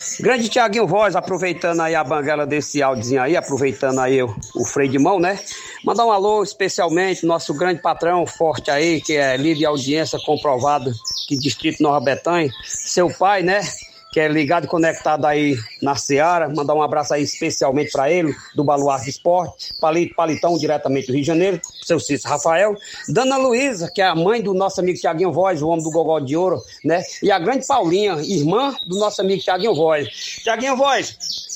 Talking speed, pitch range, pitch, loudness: 185 wpm, 145-185 Hz, 165 Hz, -18 LUFS